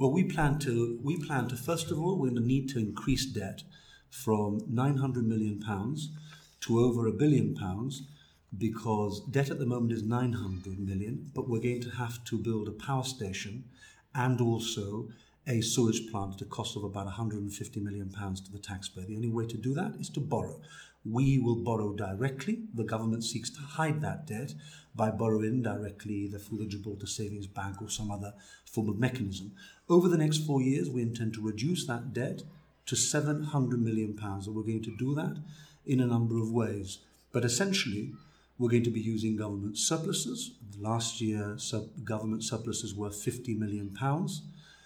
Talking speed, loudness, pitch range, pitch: 185 wpm, -32 LUFS, 105-135 Hz, 115 Hz